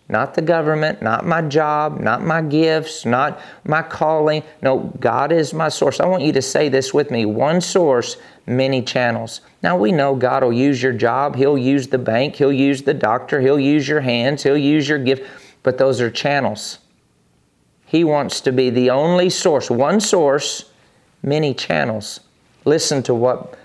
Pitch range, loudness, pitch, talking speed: 130-155 Hz, -17 LUFS, 140 Hz, 180 wpm